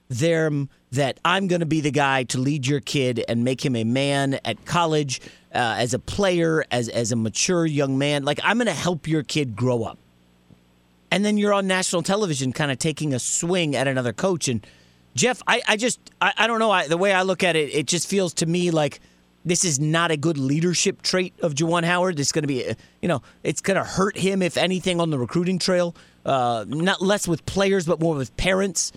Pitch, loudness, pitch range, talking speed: 160 Hz, -22 LUFS, 135-180 Hz, 230 wpm